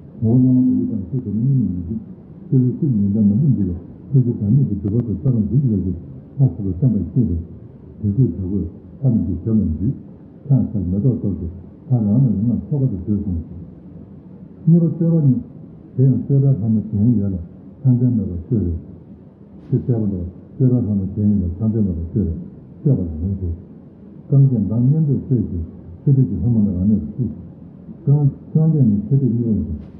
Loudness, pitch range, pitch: -19 LUFS, 95-130 Hz, 110 Hz